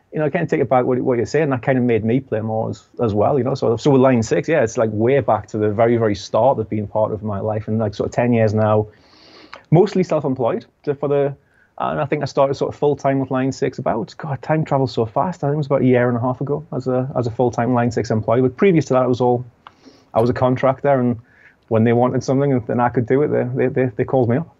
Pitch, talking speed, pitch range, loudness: 125 Hz, 300 wpm, 115-140 Hz, -18 LUFS